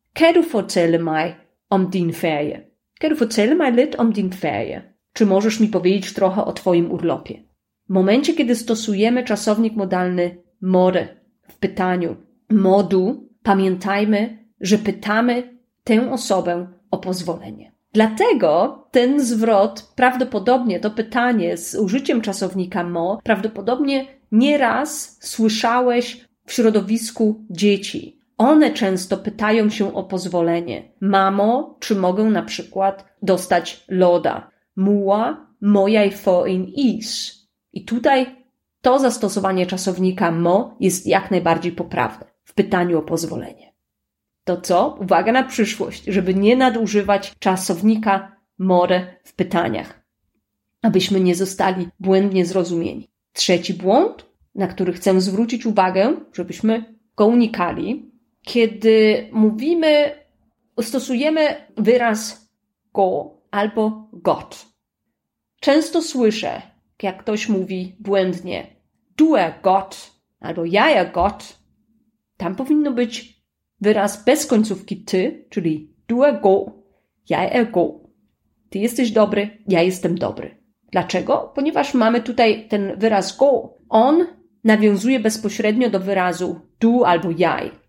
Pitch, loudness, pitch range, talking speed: 210 Hz, -19 LUFS, 185-235 Hz, 110 wpm